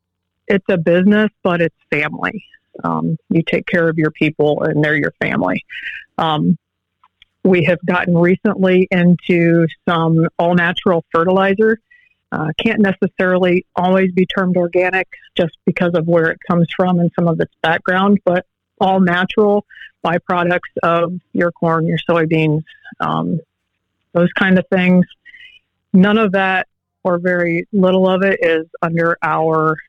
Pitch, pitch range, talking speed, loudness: 175 Hz, 165-190 Hz, 145 wpm, -15 LUFS